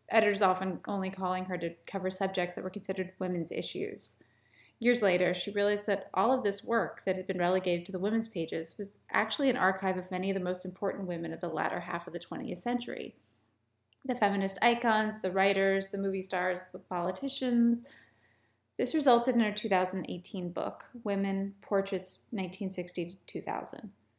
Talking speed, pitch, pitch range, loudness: 170 wpm, 190 Hz, 180-205 Hz, -32 LUFS